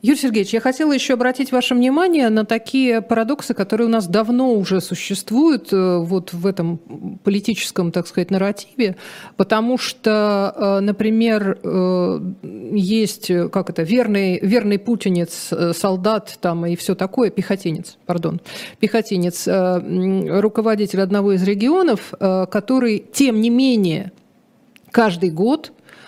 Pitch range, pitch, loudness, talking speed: 185-235 Hz, 205 Hz, -18 LUFS, 115 wpm